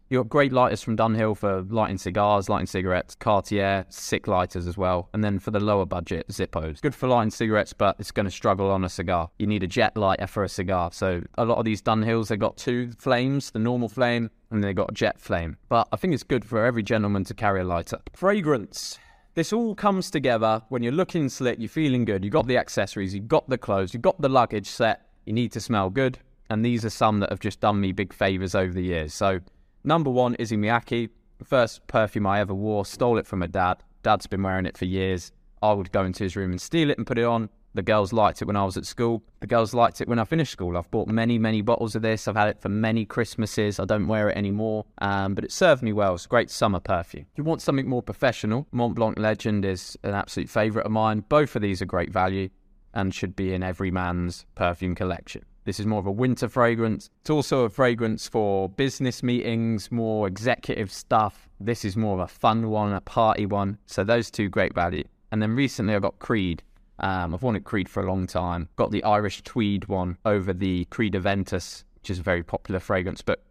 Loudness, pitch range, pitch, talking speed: -25 LUFS, 95-115 Hz, 105 Hz, 235 wpm